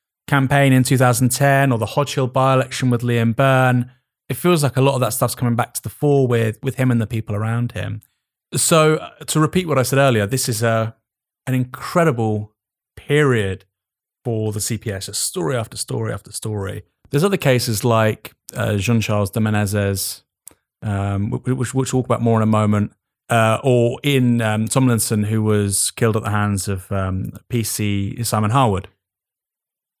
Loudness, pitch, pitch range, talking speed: -18 LUFS, 120 Hz, 105-130 Hz, 175 wpm